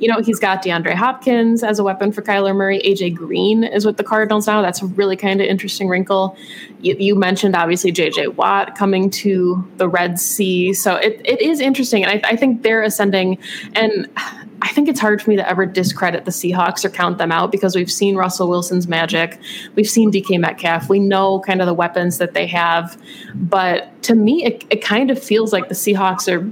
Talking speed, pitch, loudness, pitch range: 215 wpm, 195 Hz, -16 LUFS, 180-215 Hz